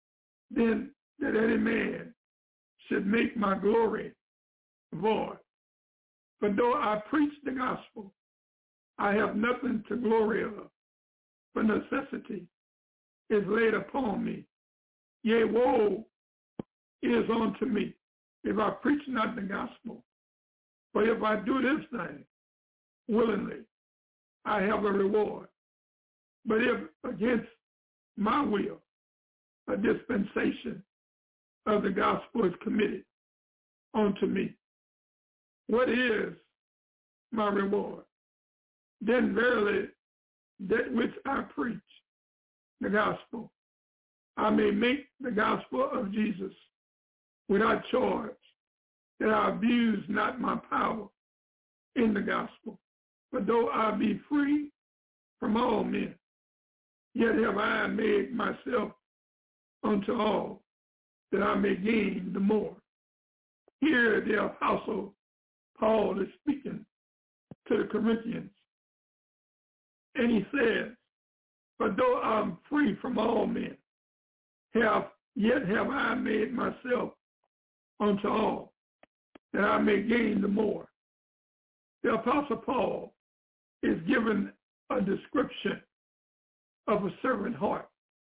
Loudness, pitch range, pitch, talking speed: -30 LUFS, 210-245 Hz, 225 Hz, 105 wpm